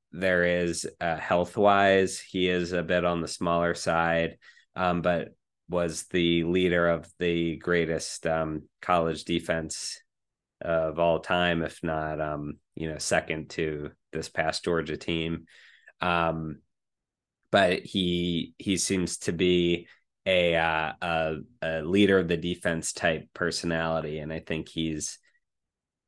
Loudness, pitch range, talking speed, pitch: -27 LUFS, 80-90 Hz, 135 wpm, 85 Hz